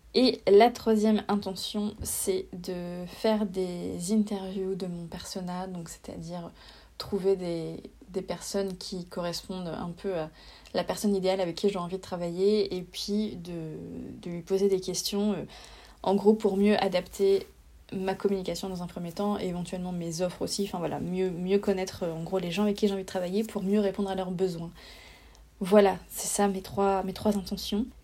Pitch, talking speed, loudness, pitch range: 190 Hz, 180 wpm, -29 LUFS, 180-205 Hz